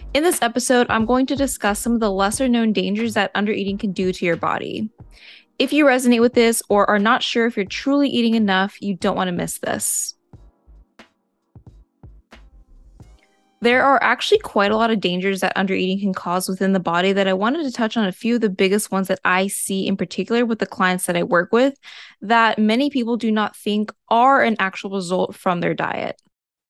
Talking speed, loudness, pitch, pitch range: 205 wpm, -19 LUFS, 210 Hz, 190-235 Hz